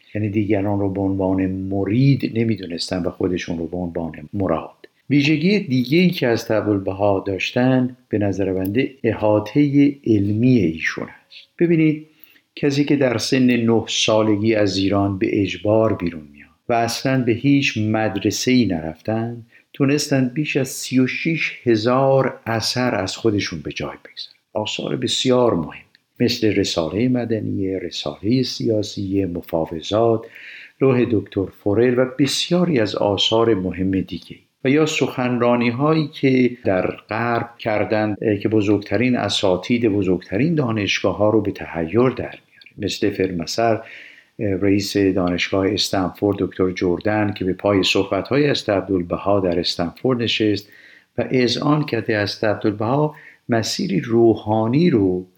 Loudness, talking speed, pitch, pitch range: -19 LUFS, 135 wpm, 110 Hz, 95-125 Hz